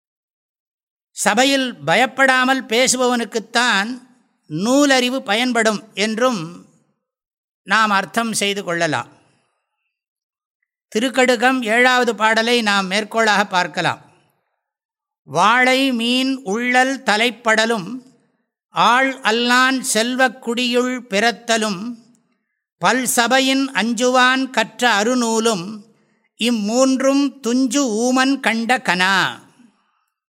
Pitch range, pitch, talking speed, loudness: 220-255 Hz, 240 Hz, 70 wpm, -16 LUFS